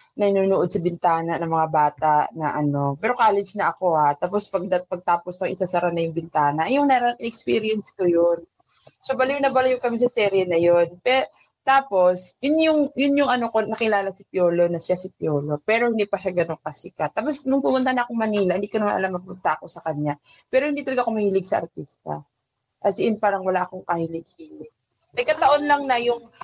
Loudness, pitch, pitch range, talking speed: -22 LUFS, 195 Hz, 170-240 Hz, 200 wpm